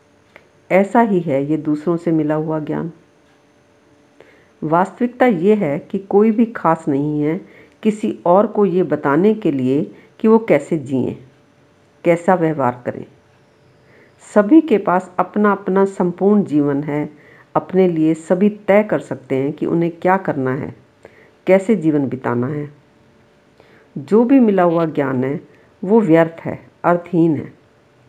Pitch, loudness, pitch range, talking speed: 170 Hz, -17 LUFS, 150-200 Hz, 145 wpm